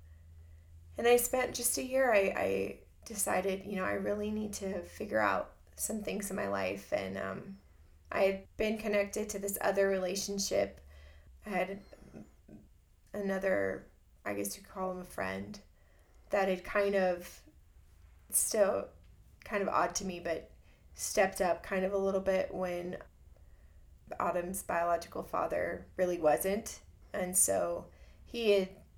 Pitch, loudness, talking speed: 175 Hz, -33 LUFS, 145 wpm